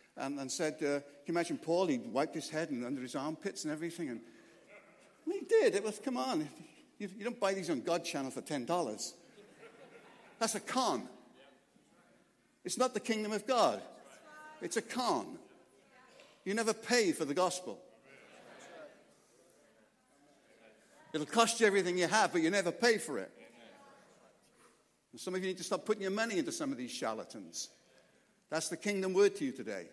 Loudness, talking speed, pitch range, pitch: -35 LUFS, 175 wpm, 170-260 Hz, 210 Hz